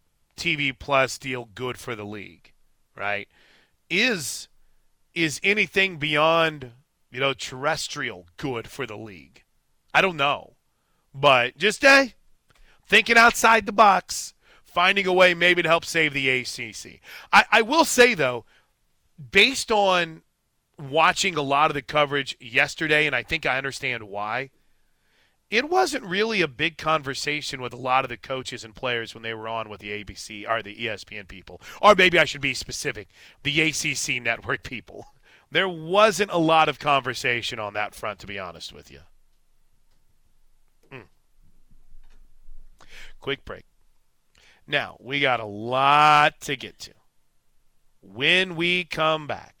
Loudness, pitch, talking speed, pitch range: -21 LUFS, 145 Hz, 150 wpm, 120-170 Hz